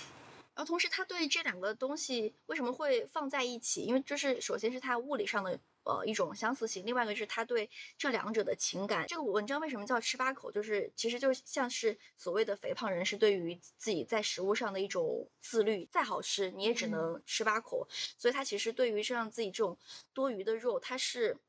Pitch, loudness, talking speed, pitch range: 250 Hz, -35 LUFS, 330 characters per minute, 220-320 Hz